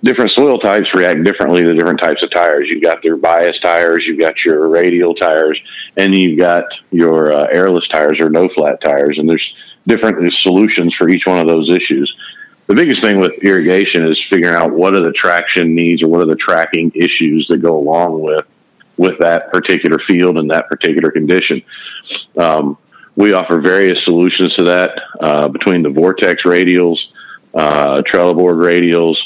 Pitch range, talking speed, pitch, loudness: 80-90 Hz, 180 wpm, 85 Hz, -11 LUFS